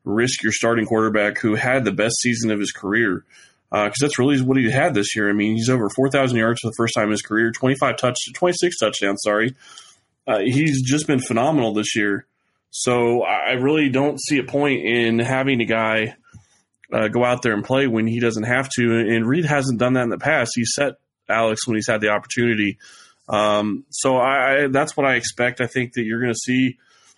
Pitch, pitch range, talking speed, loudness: 120 Hz, 110-130 Hz, 220 wpm, -19 LUFS